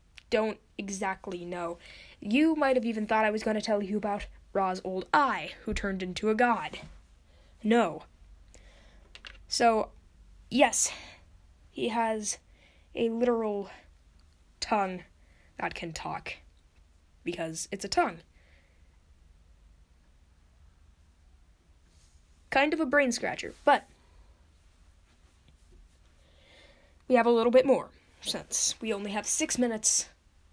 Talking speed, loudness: 110 wpm, -29 LUFS